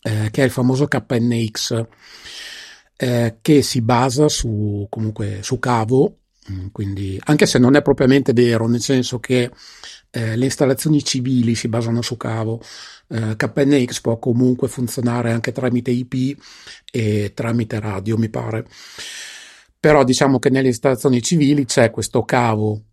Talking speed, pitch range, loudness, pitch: 140 wpm, 115-135 Hz, -18 LUFS, 125 Hz